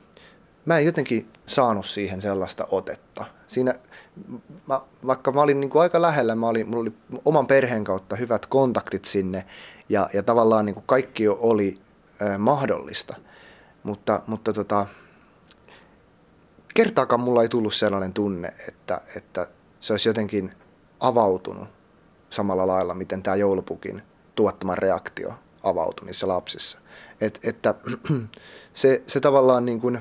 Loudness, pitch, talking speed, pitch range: -23 LUFS, 110 Hz, 135 wpm, 100-130 Hz